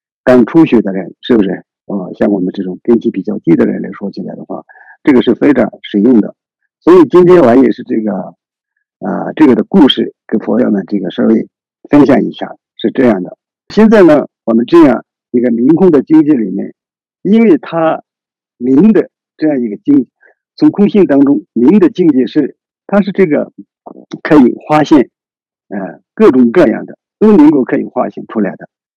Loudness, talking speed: -10 LUFS, 265 characters per minute